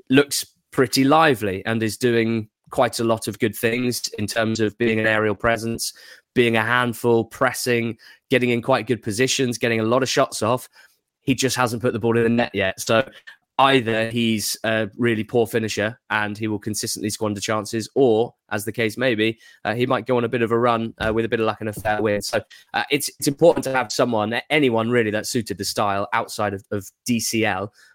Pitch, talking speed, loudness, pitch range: 115 Hz, 215 wpm, -21 LUFS, 110-125 Hz